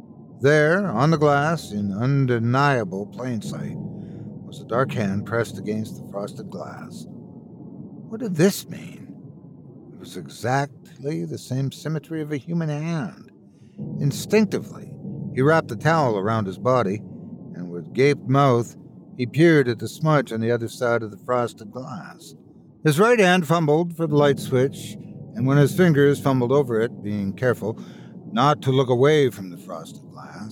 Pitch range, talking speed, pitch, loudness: 115-160 Hz, 155 wpm, 140 Hz, -21 LUFS